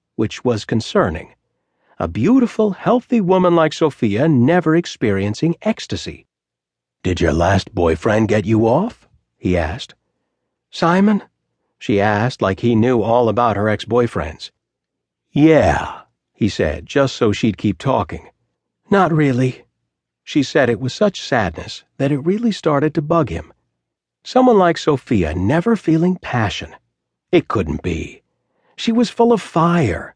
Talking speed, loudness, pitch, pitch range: 135 wpm, -17 LUFS, 130 Hz, 105-175 Hz